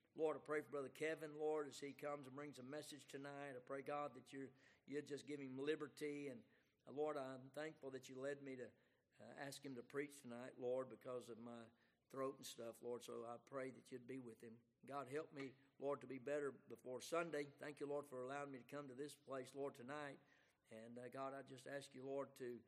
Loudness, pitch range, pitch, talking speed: -52 LUFS, 125-145 Hz, 135 Hz, 235 wpm